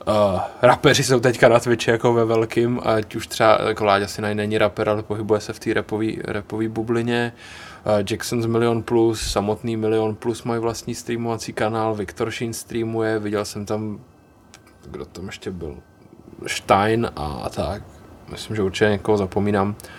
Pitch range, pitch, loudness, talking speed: 105-115 Hz, 110 Hz, -21 LUFS, 160 wpm